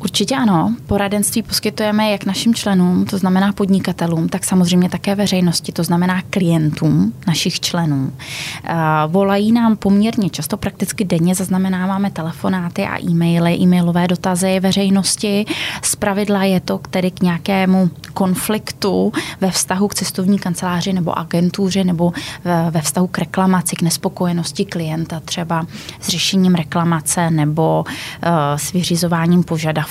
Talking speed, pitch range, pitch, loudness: 125 wpm, 170-195 Hz, 180 Hz, -16 LUFS